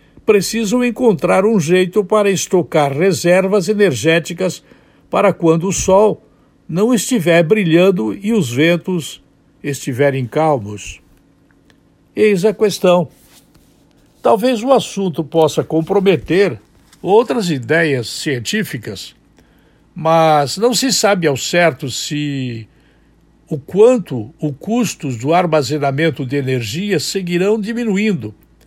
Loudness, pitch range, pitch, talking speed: -15 LUFS, 145-205 Hz, 175 Hz, 100 wpm